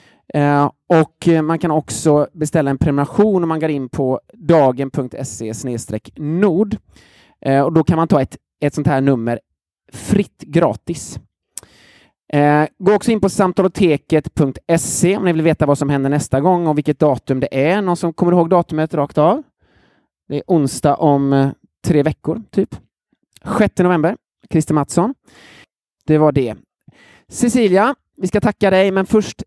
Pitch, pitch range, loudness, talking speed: 155 Hz, 140-180 Hz, -16 LUFS, 155 wpm